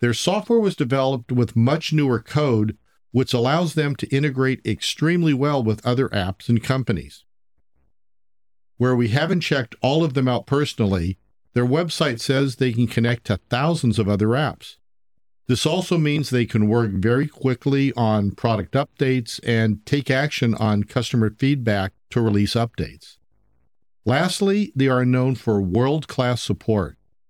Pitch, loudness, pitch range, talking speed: 120 Hz, -21 LUFS, 110-140 Hz, 150 wpm